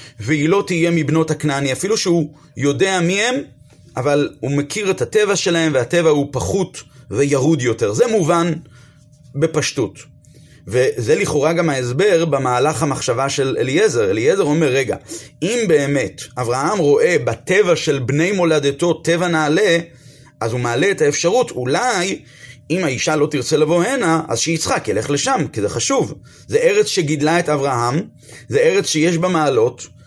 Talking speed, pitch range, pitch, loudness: 150 wpm, 140-180 Hz, 155 Hz, -17 LUFS